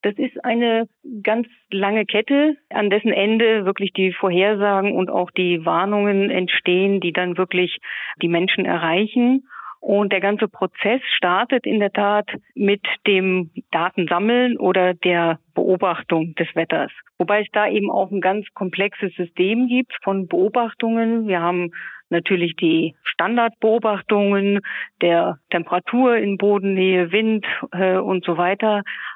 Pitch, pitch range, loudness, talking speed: 200 Hz, 180-215 Hz, -19 LUFS, 130 wpm